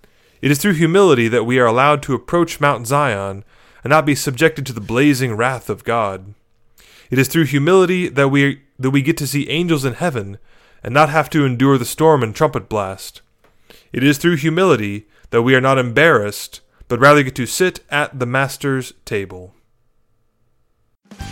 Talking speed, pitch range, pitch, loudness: 180 wpm, 115-150 Hz, 135 Hz, -16 LUFS